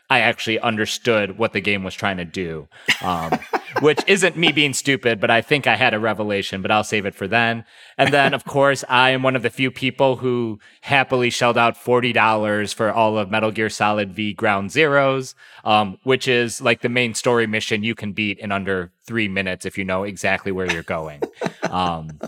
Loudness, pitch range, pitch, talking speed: -19 LUFS, 100-125 Hz, 110 Hz, 205 wpm